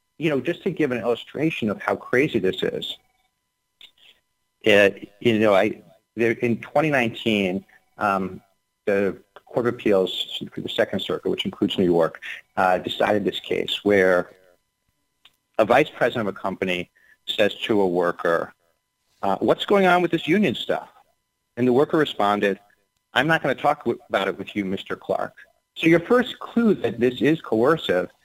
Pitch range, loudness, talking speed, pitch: 100-160 Hz, -22 LUFS, 170 wpm, 120 Hz